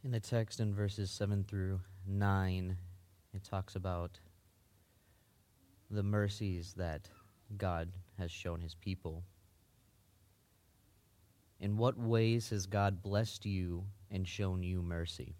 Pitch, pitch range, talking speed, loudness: 95 Hz, 90-105 Hz, 115 wpm, -38 LUFS